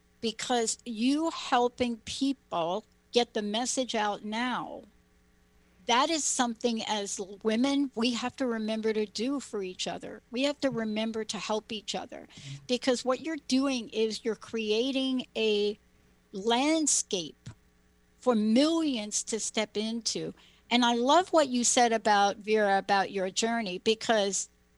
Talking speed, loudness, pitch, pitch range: 140 wpm, -29 LUFS, 225 Hz, 210-250 Hz